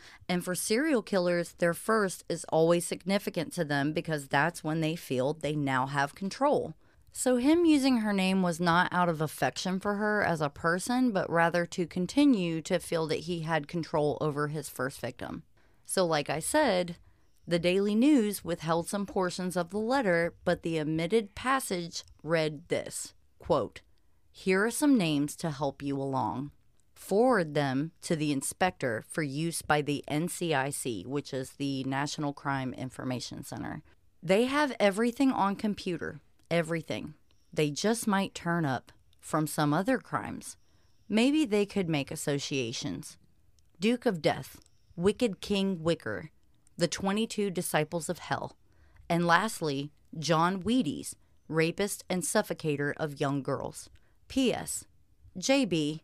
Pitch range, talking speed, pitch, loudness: 145-195 Hz, 145 wpm, 170 Hz, -30 LUFS